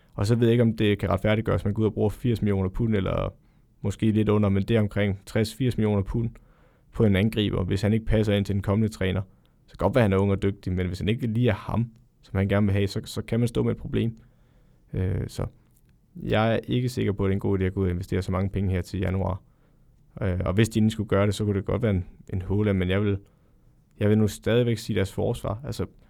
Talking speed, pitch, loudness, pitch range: 275 wpm, 105 Hz, -25 LUFS, 100-115 Hz